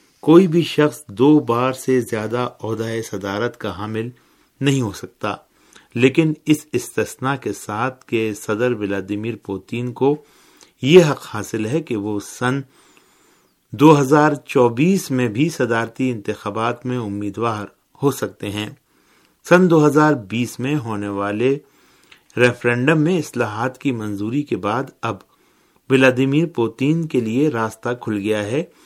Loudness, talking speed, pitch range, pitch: -19 LUFS, 135 wpm, 110-145 Hz, 125 Hz